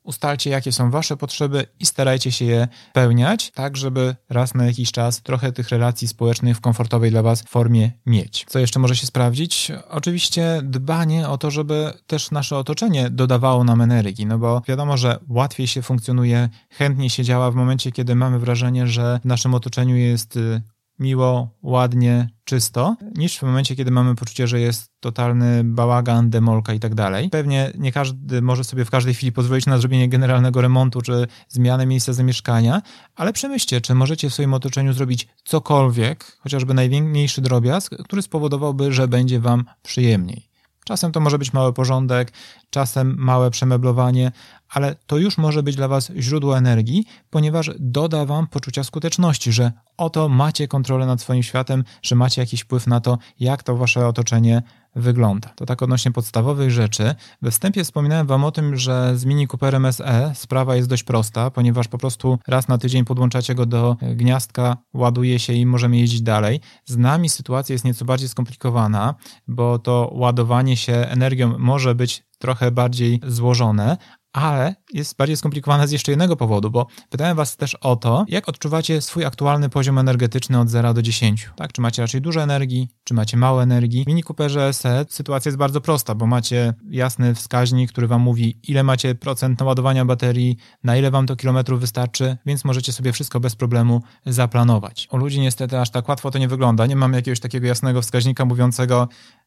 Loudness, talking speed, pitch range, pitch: -19 LUFS, 175 wpm, 120-135 Hz, 125 Hz